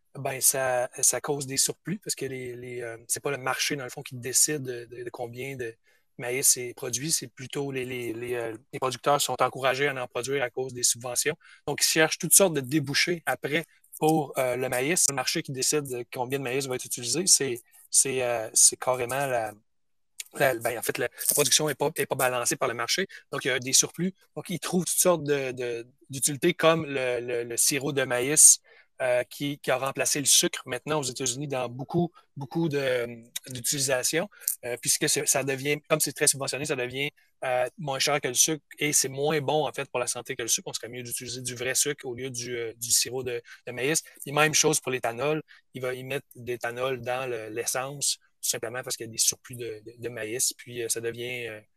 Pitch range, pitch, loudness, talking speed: 125-150 Hz, 130 Hz, -26 LUFS, 230 wpm